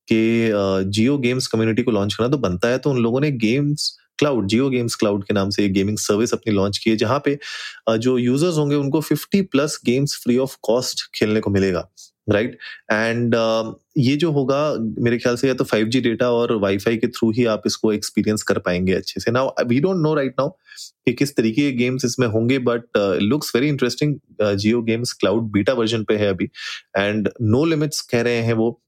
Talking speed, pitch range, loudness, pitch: 210 wpm, 110-130 Hz, -20 LUFS, 120 Hz